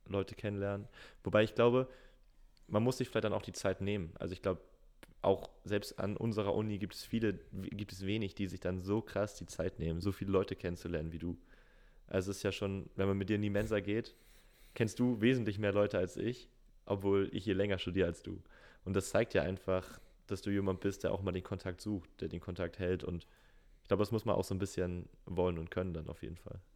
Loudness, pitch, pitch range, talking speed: -37 LUFS, 100 Hz, 90-105 Hz, 235 wpm